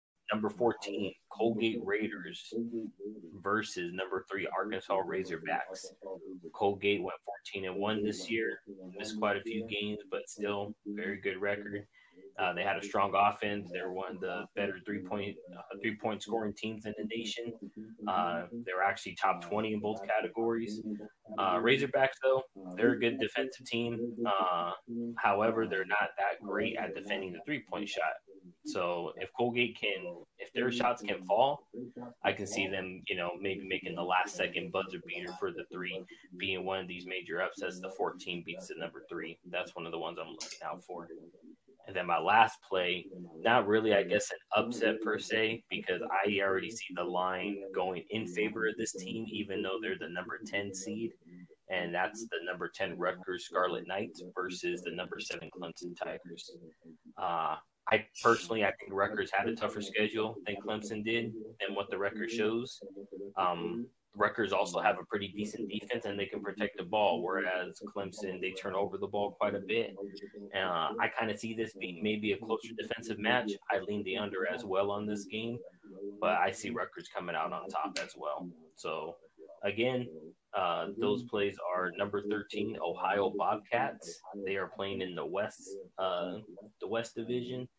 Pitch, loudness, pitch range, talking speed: 105 Hz, -34 LUFS, 95-115 Hz, 175 wpm